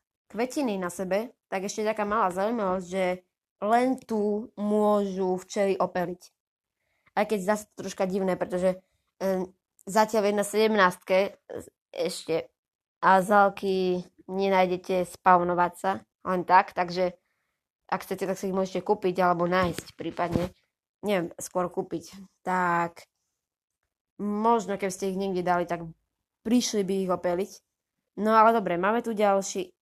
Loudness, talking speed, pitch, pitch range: -27 LUFS, 135 wpm, 190 Hz, 180-210 Hz